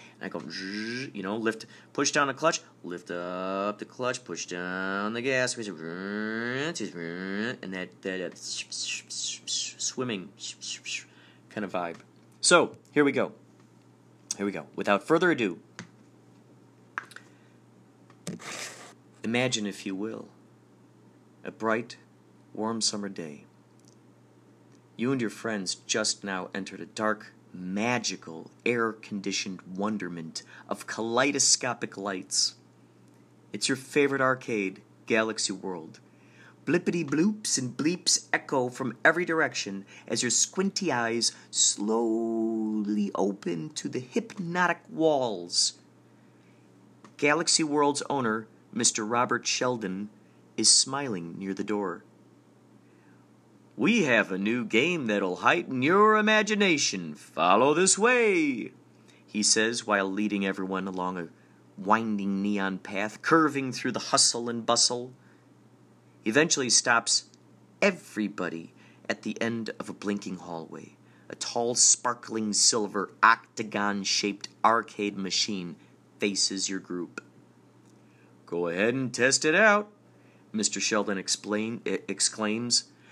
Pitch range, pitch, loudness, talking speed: 95-125 Hz, 110 Hz, -27 LUFS, 110 wpm